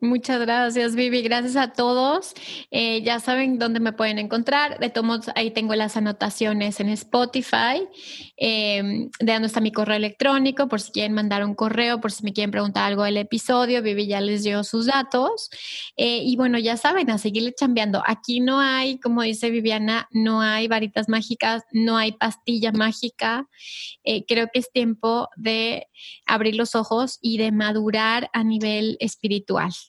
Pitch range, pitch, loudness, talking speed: 215-245 Hz, 230 Hz, -22 LUFS, 175 wpm